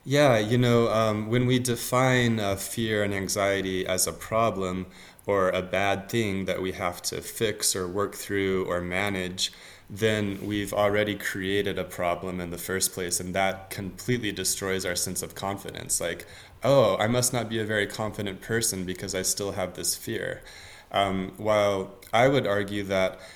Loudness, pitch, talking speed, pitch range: -26 LUFS, 100 Hz, 175 wpm, 95-110 Hz